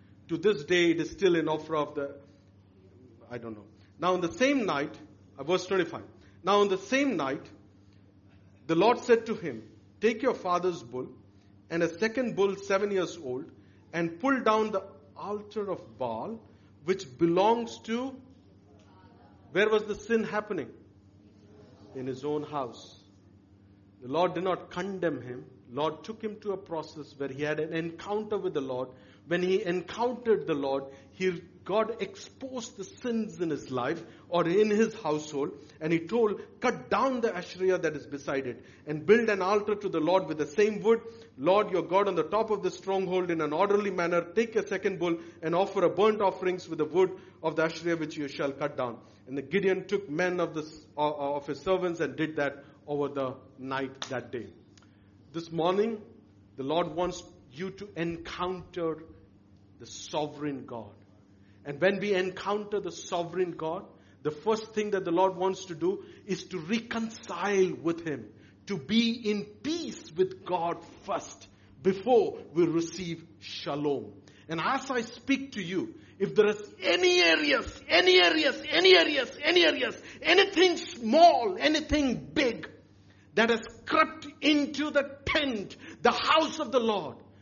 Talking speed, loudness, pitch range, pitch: 170 wpm, -29 LUFS, 135-210 Hz, 175 Hz